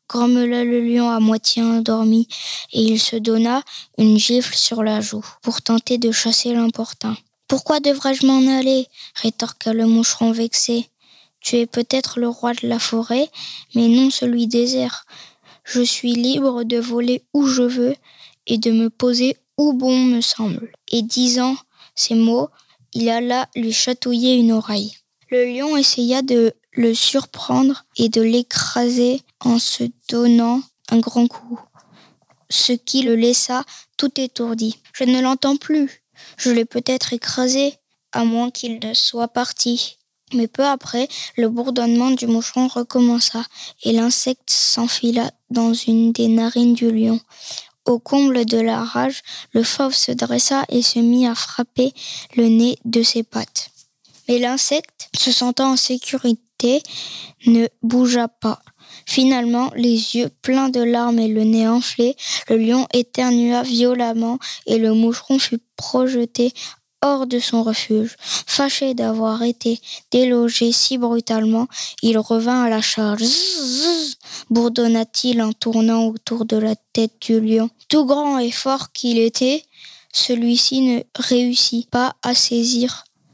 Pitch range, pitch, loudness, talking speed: 230-255 Hz, 240 Hz, -18 LUFS, 150 wpm